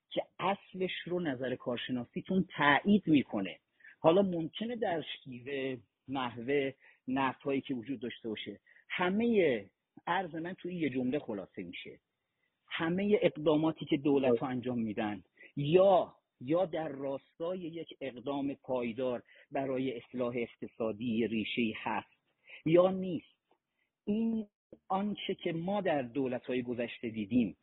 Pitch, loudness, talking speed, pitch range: 140 Hz, -33 LUFS, 115 wpm, 125-175 Hz